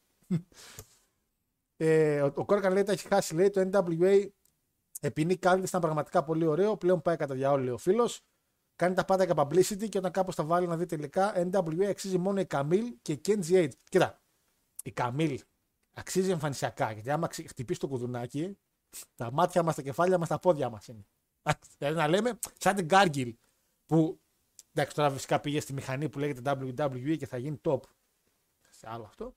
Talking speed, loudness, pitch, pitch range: 180 wpm, -29 LUFS, 165 Hz, 140-185 Hz